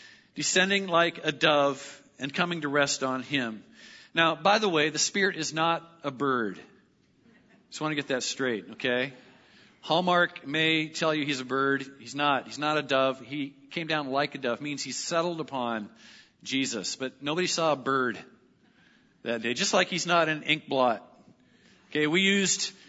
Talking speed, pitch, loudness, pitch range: 180 wpm, 145 Hz, -27 LUFS, 135-165 Hz